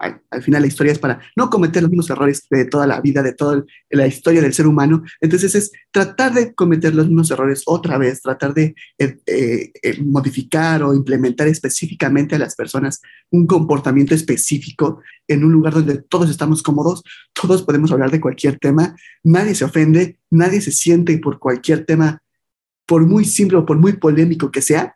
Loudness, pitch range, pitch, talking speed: -15 LUFS, 140-170 Hz, 155 Hz, 190 wpm